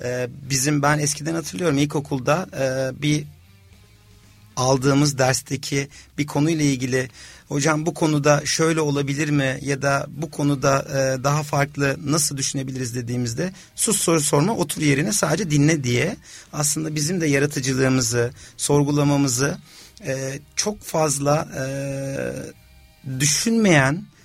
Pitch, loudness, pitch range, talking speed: 140 Hz, -21 LUFS, 130-150 Hz, 105 wpm